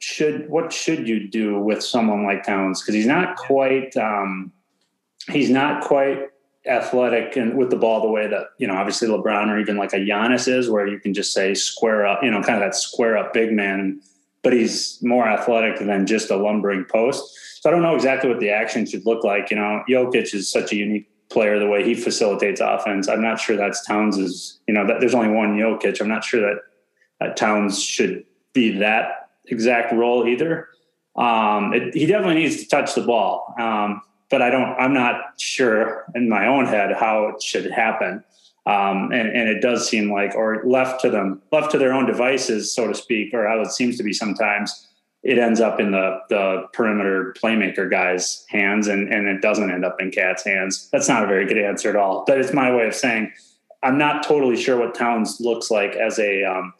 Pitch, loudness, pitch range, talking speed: 110 Hz, -20 LUFS, 100-120 Hz, 215 wpm